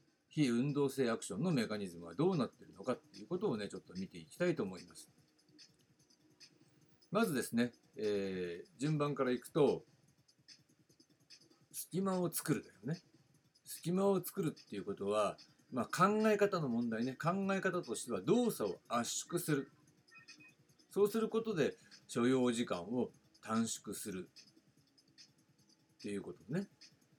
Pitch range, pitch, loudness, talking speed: 120-175 Hz, 150 Hz, -38 LUFS, 280 characters per minute